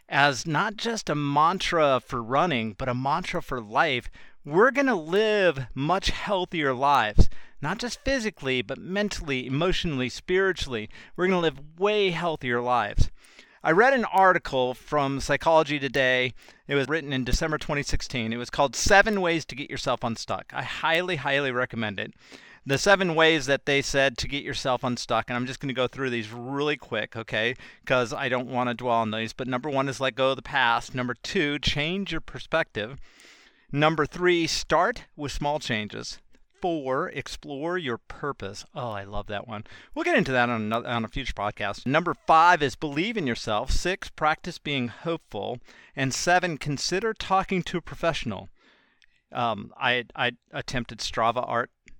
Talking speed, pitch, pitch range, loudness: 170 wpm, 140 Hz, 125-165 Hz, -26 LUFS